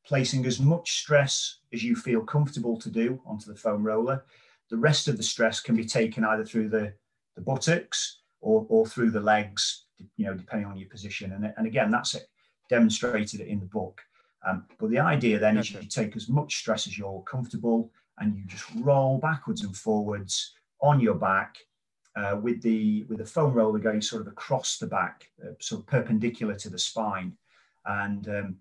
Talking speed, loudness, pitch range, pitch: 195 wpm, -27 LUFS, 105-135 Hz, 110 Hz